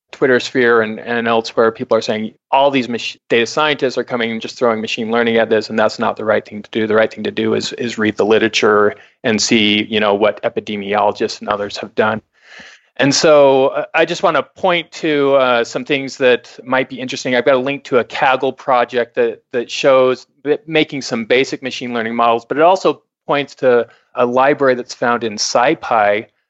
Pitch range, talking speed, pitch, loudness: 110-135 Hz, 215 wpm, 120 Hz, -15 LUFS